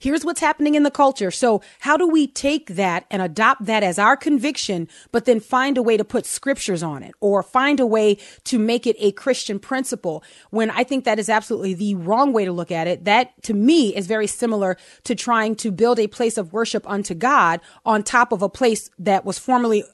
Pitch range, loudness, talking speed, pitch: 200-255 Hz, -20 LUFS, 225 wpm, 220 Hz